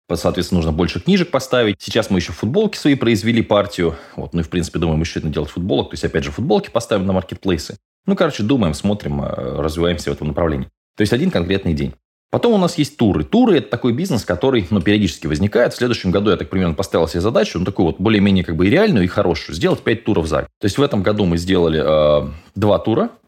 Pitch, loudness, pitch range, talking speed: 90 Hz, -17 LUFS, 85-105 Hz, 230 wpm